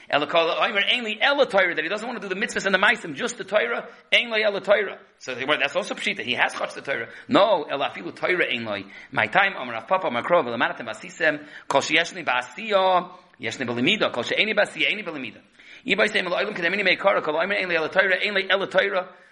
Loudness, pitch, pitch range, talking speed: -22 LUFS, 190 Hz, 175-210 Hz, 245 wpm